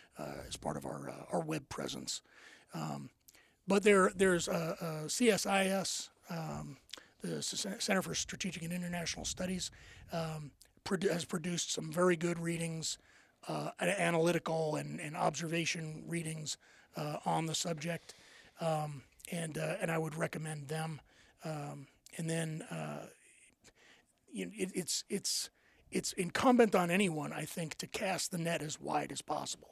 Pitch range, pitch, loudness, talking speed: 160-185 Hz, 170 Hz, -36 LUFS, 145 wpm